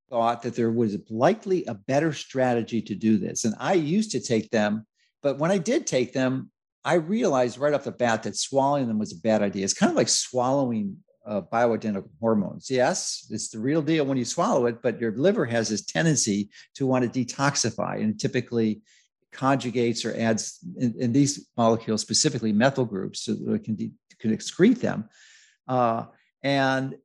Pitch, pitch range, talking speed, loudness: 125 Hz, 110-140 Hz, 190 wpm, -25 LUFS